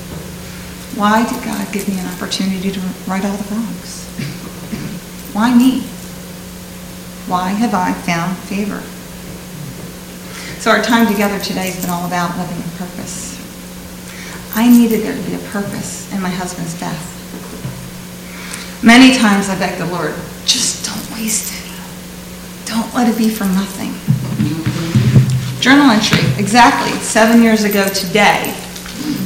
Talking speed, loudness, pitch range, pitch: 135 wpm, -14 LUFS, 175-220 Hz, 195 Hz